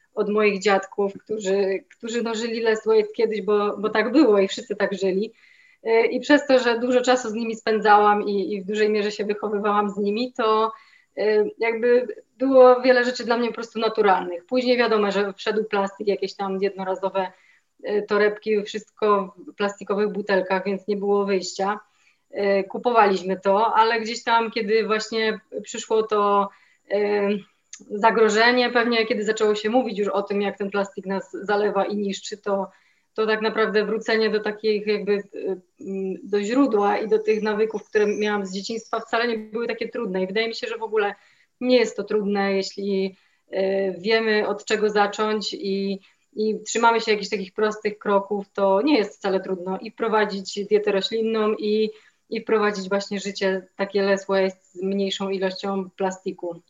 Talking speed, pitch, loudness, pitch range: 165 wpm, 210 Hz, -22 LUFS, 200-225 Hz